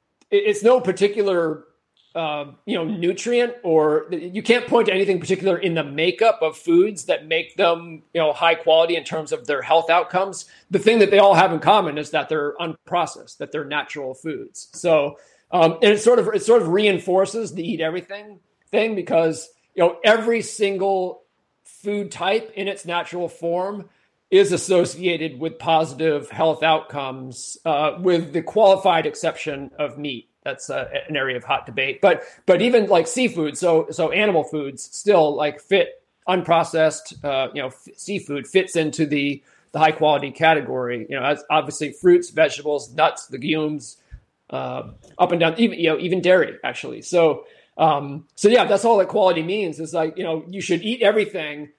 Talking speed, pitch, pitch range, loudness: 175 wpm, 170 Hz, 155-200 Hz, -20 LUFS